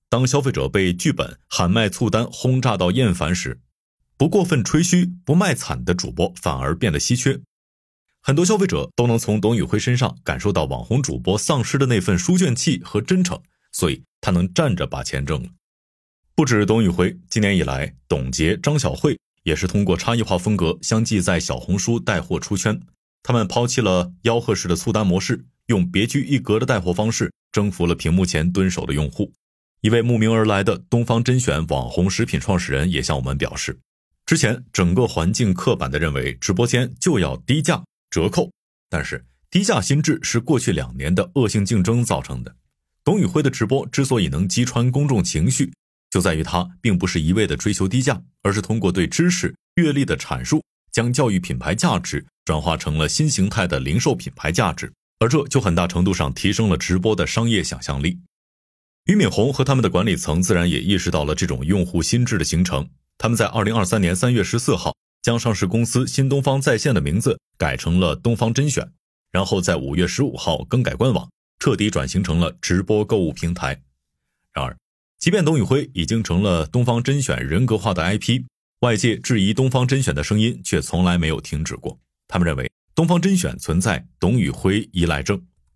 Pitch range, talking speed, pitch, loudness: 85-125 Hz, 300 characters per minute, 105 Hz, -20 LUFS